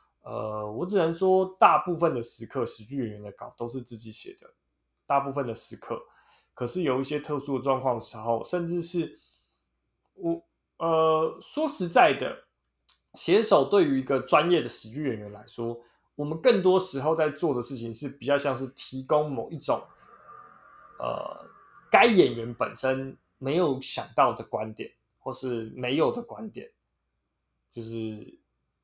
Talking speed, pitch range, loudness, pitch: 225 characters per minute, 115-160 Hz, -27 LUFS, 130 Hz